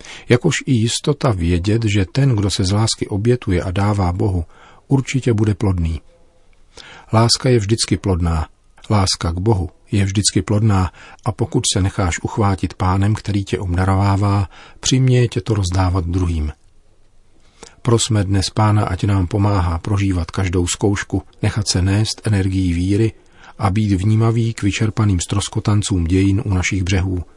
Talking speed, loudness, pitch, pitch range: 145 wpm, -18 LUFS, 100 Hz, 95-110 Hz